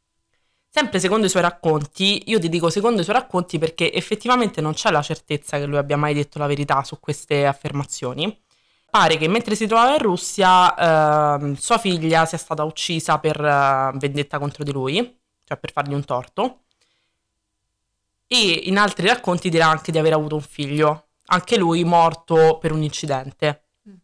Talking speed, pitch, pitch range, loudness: 170 wpm, 160 Hz, 145-185 Hz, -19 LUFS